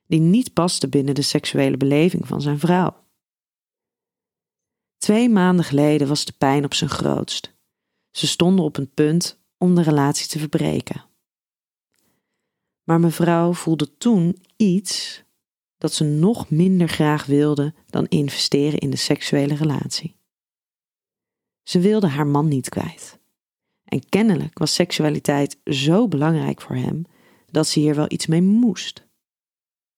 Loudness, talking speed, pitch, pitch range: -19 LUFS, 135 wpm, 160 Hz, 145-180 Hz